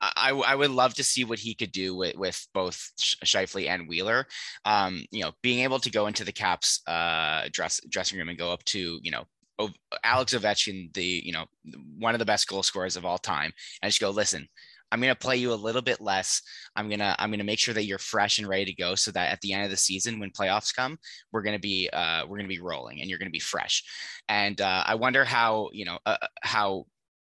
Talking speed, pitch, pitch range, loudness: 245 wpm, 105 Hz, 95-120 Hz, -27 LUFS